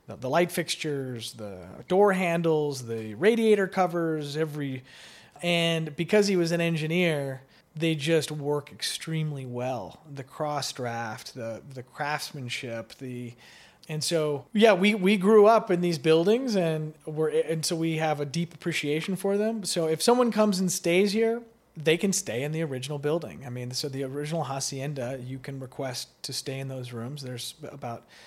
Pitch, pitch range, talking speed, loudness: 155 Hz, 135-175 Hz, 170 wpm, -27 LUFS